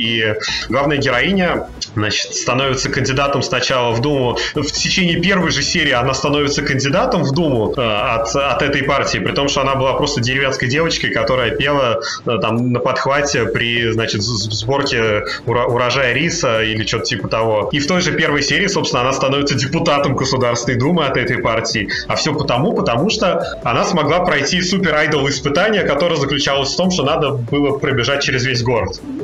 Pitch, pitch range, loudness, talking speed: 140 Hz, 120-145 Hz, -16 LUFS, 170 wpm